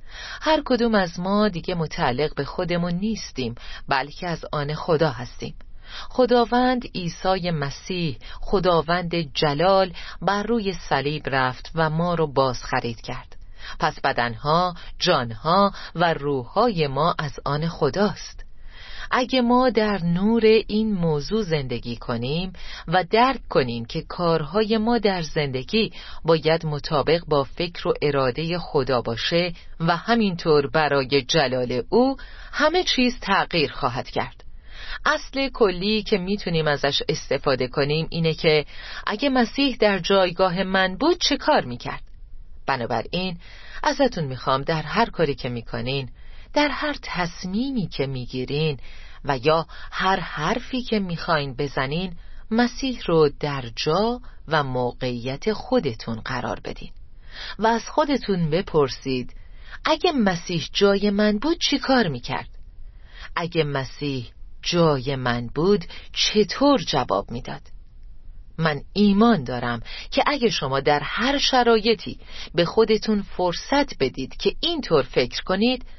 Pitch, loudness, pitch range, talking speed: 170 Hz, -22 LUFS, 140-215 Hz, 125 wpm